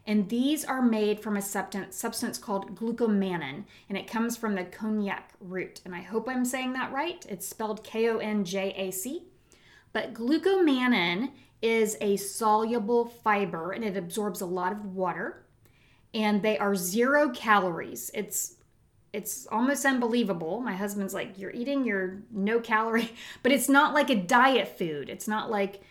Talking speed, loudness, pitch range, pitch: 155 wpm, -28 LUFS, 195-240 Hz, 215 Hz